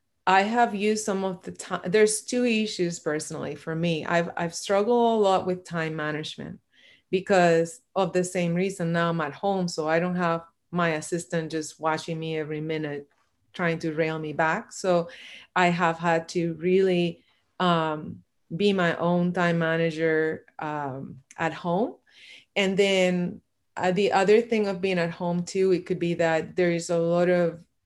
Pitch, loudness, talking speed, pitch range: 175 Hz, -25 LUFS, 175 wpm, 165-190 Hz